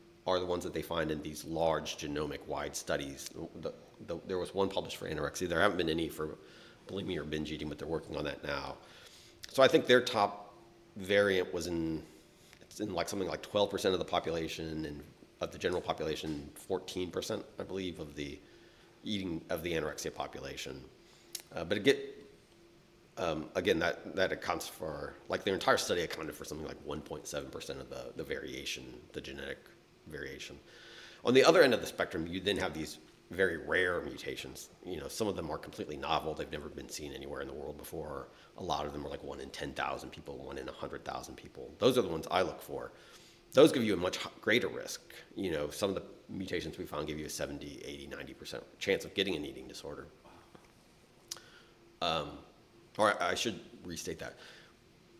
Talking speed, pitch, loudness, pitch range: 200 wpm, 80 Hz, -35 LUFS, 75-95 Hz